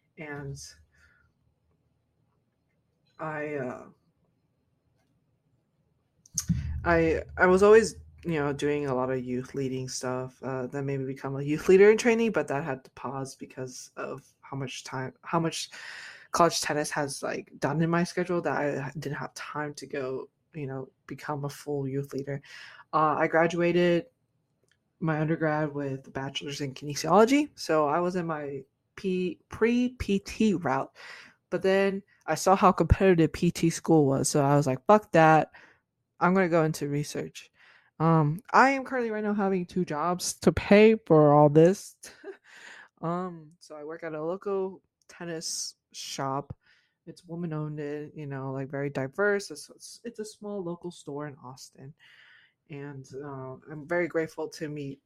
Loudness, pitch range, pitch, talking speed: -27 LUFS, 140-175 Hz, 155 Hz, 155 wpm